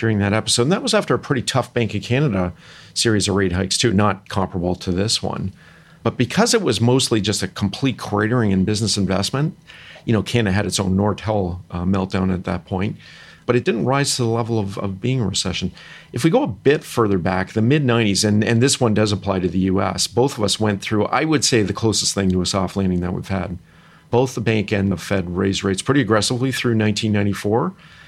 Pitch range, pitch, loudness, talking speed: 95-120 Hz, 105 Hz, -19 LUFS, 230 wpm